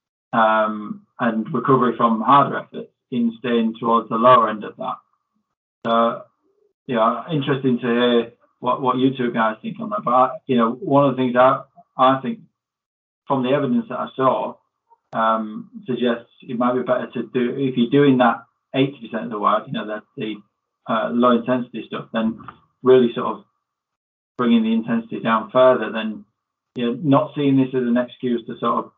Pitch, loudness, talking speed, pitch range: 125 Hz, -20 LUFS, 185 wpm, 115-140 Hz